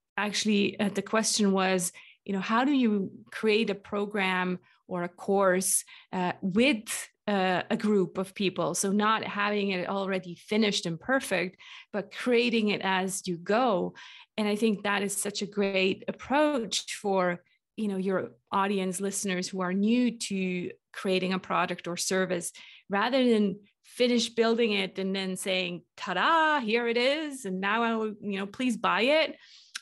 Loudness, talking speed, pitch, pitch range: -28 LUFS, 165 wpm, 200 Hz, 185-220 Hz